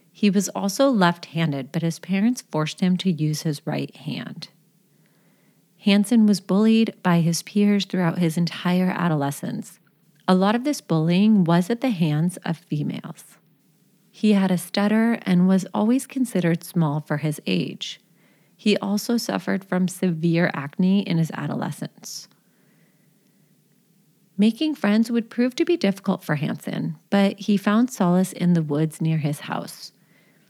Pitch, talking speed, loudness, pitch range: 185 Hz, 150 wpm, -22 LUFS, 165-205 Hz